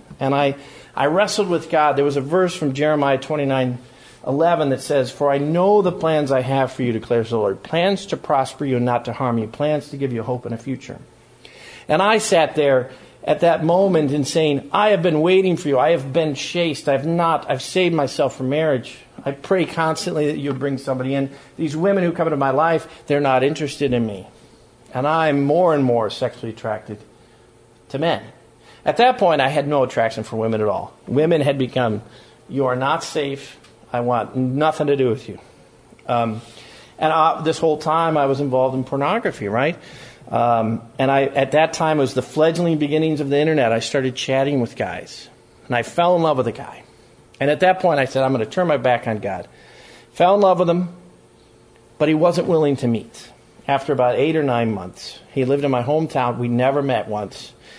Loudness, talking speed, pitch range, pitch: -19 LUFS, 210 wpm, 120-160 Hz, 140 Hz